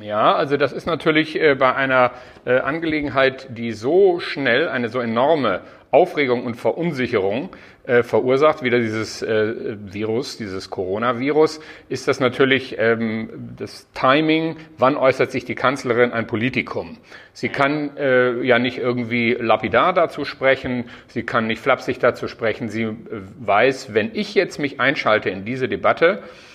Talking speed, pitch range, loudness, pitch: 135 wpm, 115-145 Hz, -19 LUFS, 125 Hz